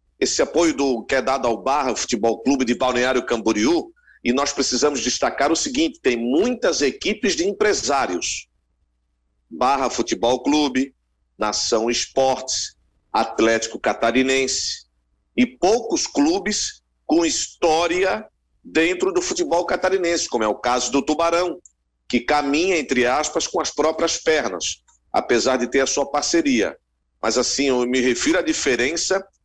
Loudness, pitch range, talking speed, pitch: -20 LUFS, 120-170 Hz, 135 wpm, 135 Hz